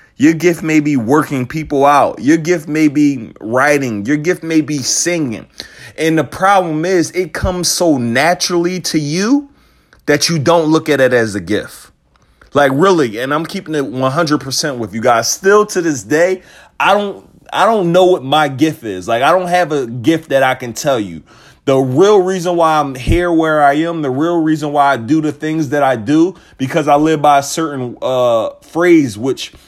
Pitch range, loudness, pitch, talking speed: 140-175 Hz, -13 LUFS, 155 Hz, 200 wpm